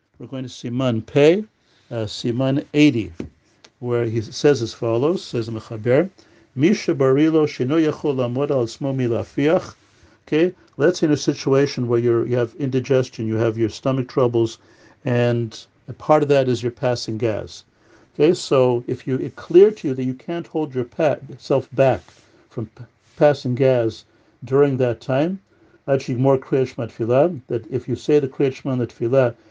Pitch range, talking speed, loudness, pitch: 115-140 Hz, 155 wpm, -20 LUFS, 125 Hz